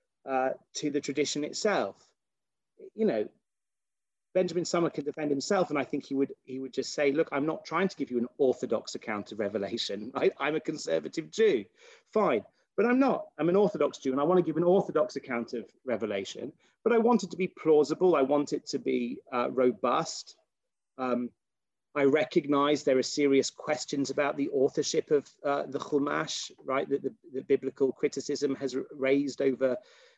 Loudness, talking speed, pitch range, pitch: -29 LUFS, 185 wpm, 135-170 Hz, 145 Hz